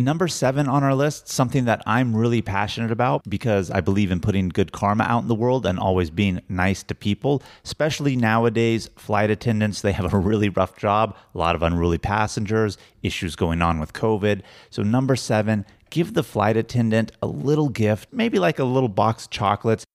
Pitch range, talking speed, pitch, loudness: 100-125 Hz, 195 wpm, 110 Hz, -22 LUFS